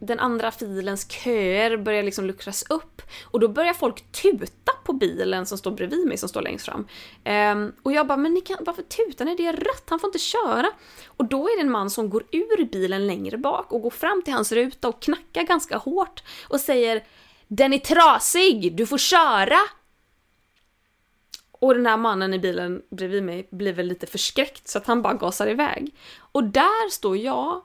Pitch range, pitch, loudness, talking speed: 210-340 Hz, 260 Hz, -22 LUFS, 200 wpm